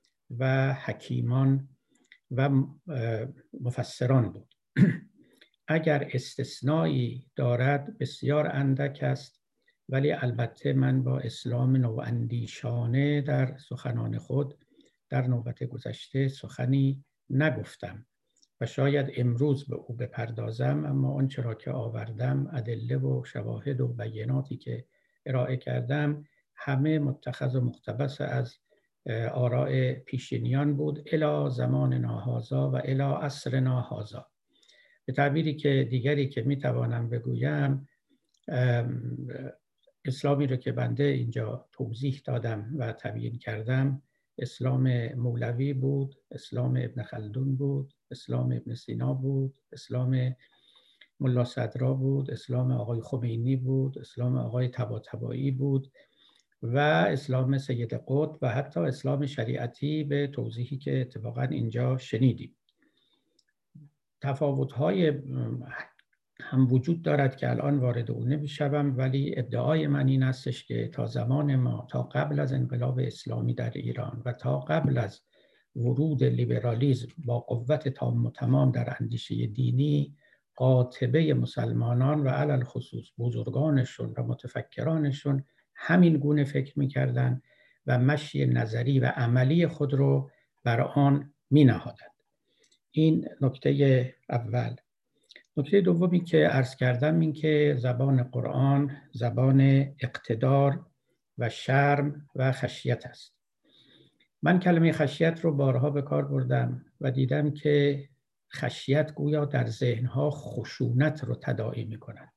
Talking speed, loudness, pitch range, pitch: 115 wpm, -28 LUFS, 125-145 Hz, 130 Hz